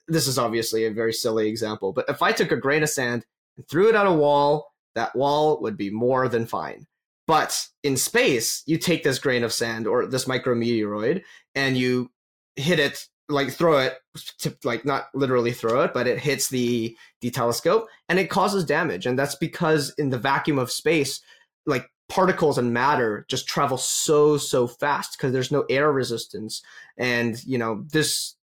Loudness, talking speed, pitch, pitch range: -23 LUFS, 185 wpm, 130 Hz, 120-150 Hz